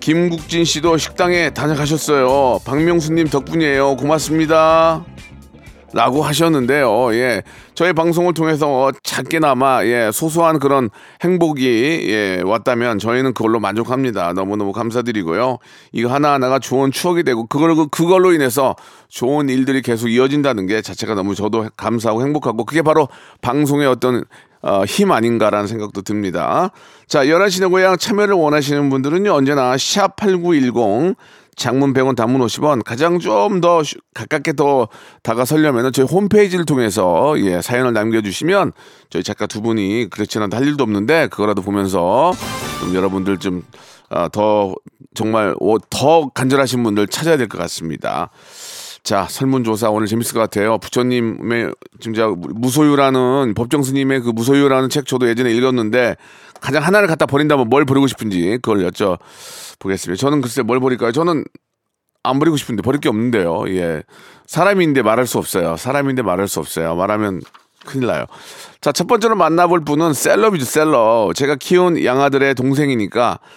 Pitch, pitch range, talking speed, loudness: 130 Hz, 110-155 Hz, 345 characters per minute, -16 LUFS